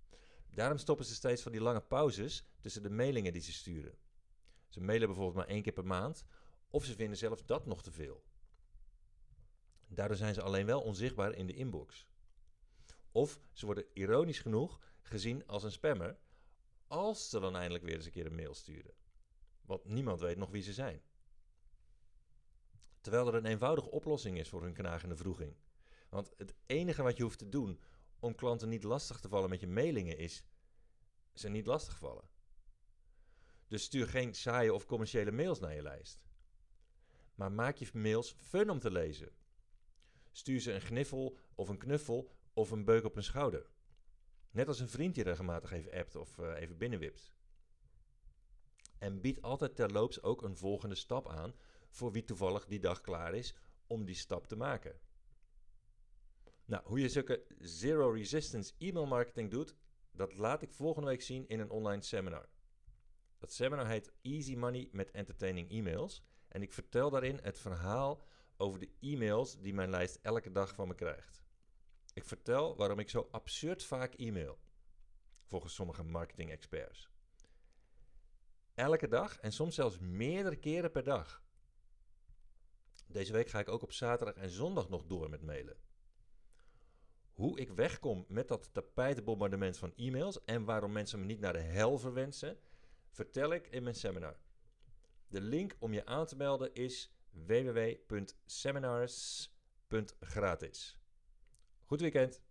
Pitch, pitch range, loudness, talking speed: 105 Hz, 95-125 Hz, -39 LUFS, 160 wpm